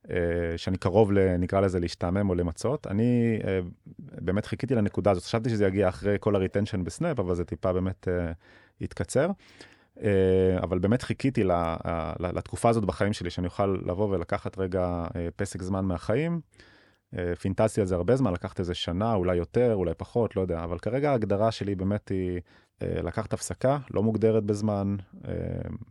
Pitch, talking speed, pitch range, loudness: 95 Hz, 150 wpm, 90-110 Hz, -28 LUFS